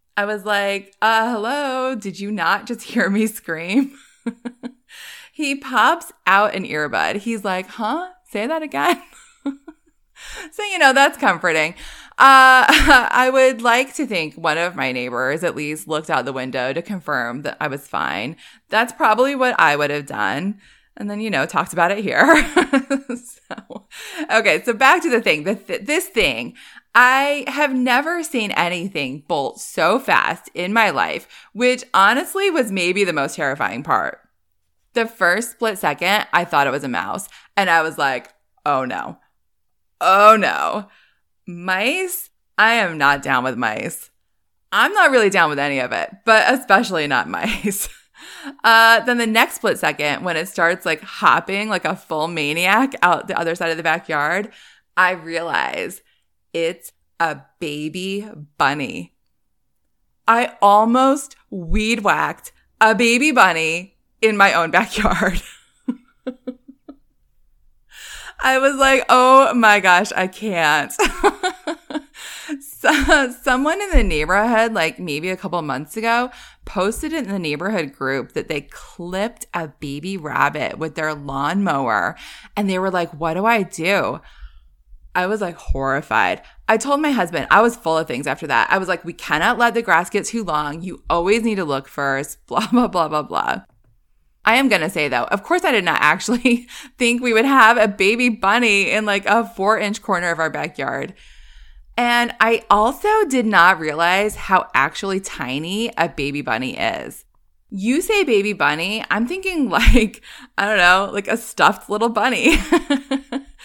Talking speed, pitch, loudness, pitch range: 160 wpm, 210 Hz, -17 LUFS, 165-255 Hz